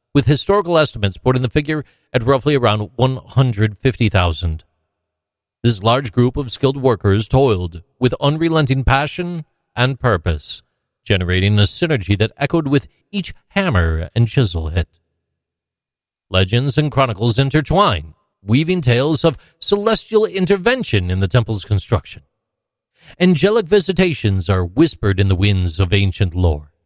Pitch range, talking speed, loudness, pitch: 95-145 Hz, 125 wpm, -17 LUFS, 120 Hz